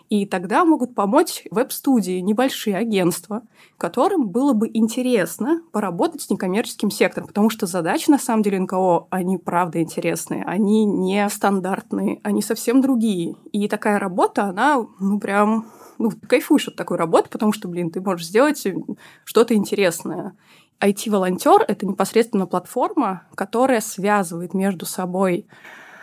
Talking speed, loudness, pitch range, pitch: 135 wpm, -20 LUFS, 185-230 Hz, 205 Hz